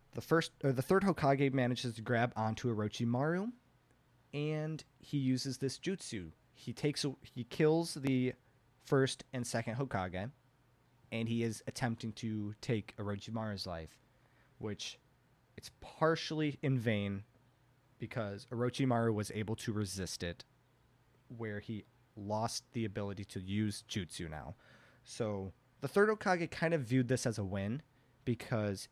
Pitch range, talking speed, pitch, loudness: 110-135 Hz, 135 wpm, 120 Hz, -37 LUFS